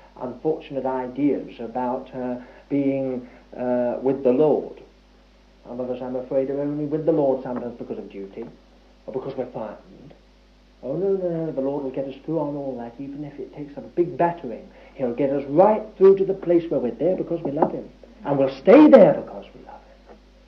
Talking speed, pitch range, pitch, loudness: 205 wpm, 125-160 Hz, 135 Hz, -21 LUFS